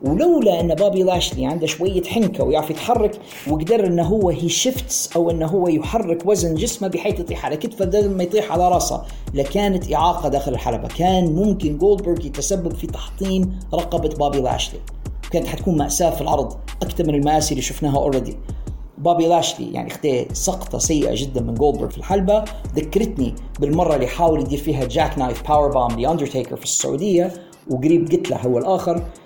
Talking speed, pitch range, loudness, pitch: 165 wpm, 145-185 Hz, -19 LUFS, 170 Hz